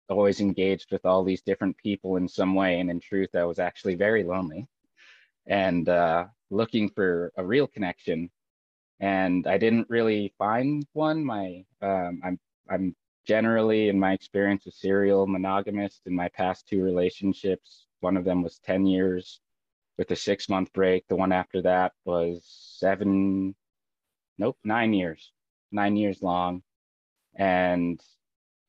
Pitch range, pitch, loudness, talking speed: 90-100 Hz, 95 Hz, -26 LUFS, 145 wpm